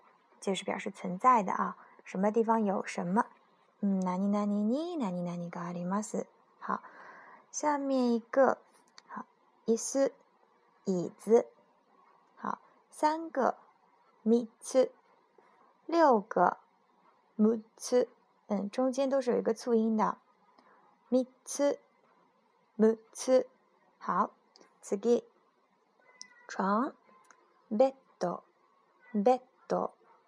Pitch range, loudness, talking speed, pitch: 210-295 Hz, -31 LUFS, 160 characters per minute, 240 Hz